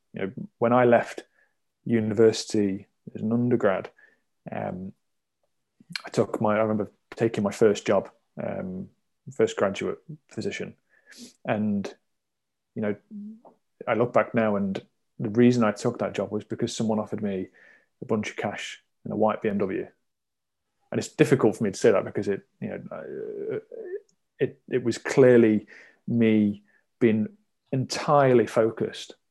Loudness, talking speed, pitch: -25 LUFS, 145 wpm, 115 Hz